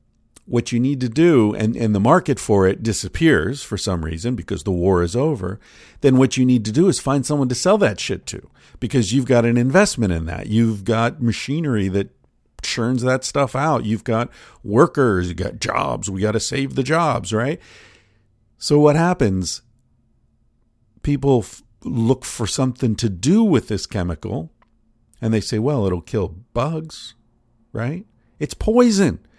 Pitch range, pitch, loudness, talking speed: 110-135 Hz, 120 Hz, -19 LUFS, 175 wpm